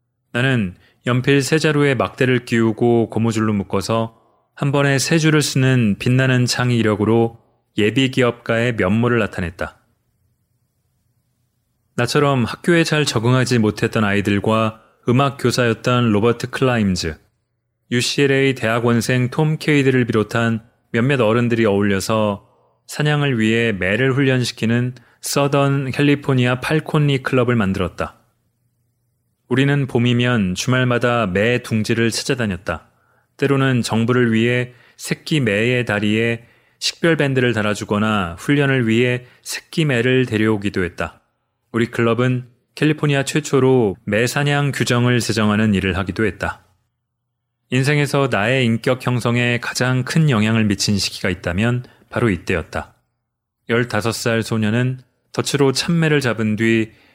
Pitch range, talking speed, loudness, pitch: 110-130 Hz, 285 characters per minute, -18 LUFS, 120 Hz